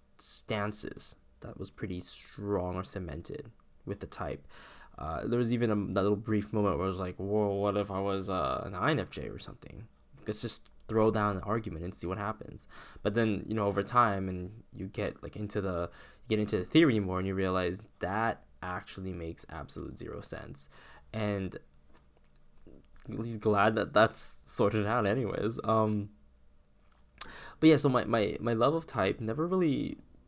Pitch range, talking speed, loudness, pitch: 90-110 Hz, 180 wpm, -32 LUFS, 100 Hz